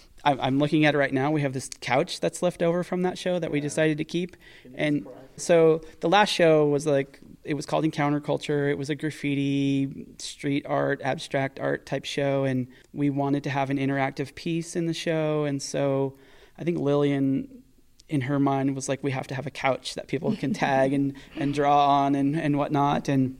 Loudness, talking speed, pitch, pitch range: -25 LUFS, 210 wpm, 145 Hz, 135-155 Hz